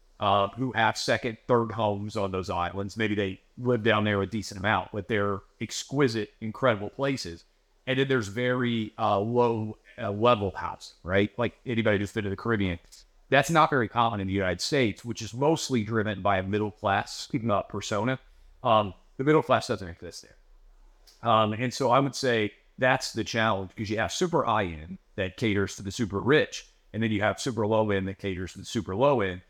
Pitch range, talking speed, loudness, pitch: 100-120 Hz, 190 wpm, -27 LUFS, 110 Hz